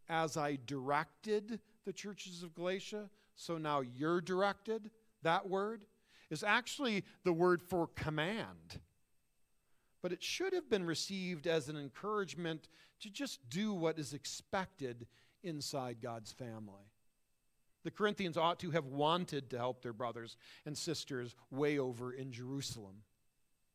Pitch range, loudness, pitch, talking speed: 130-195 Hz, -39 LUFS, 160 Hz, 135 wpm